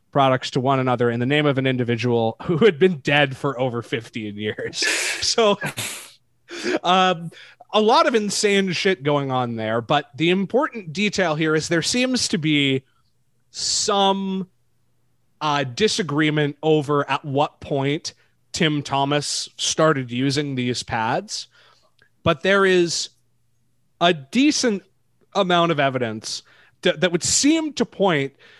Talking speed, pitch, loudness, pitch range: 135 wpm, 150 Hz, -20 LUFS, 130-190 Hz